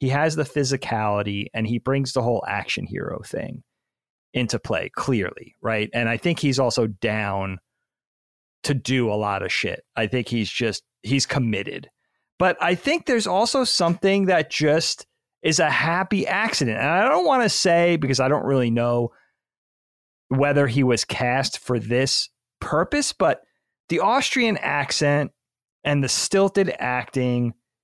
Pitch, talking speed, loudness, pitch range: 130 Hz, 155 wpm, -22 LUFS, 115-150 Hz